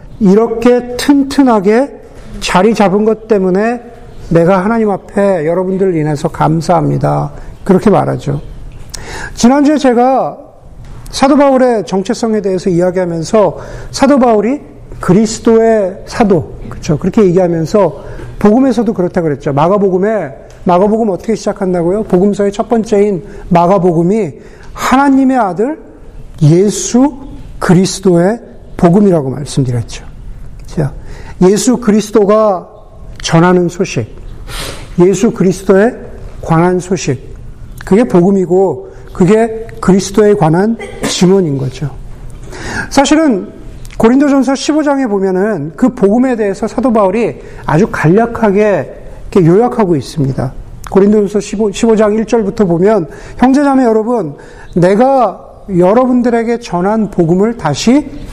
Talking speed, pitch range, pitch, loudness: 275 characters per minute, 175-230 Hz, 200 Hz, -11 LUFS